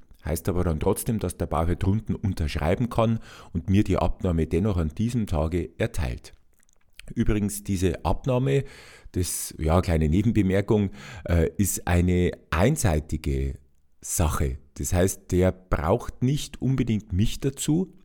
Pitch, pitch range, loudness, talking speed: 95 Hz, 80-110 Hz, -26 LUFS, 125 wpm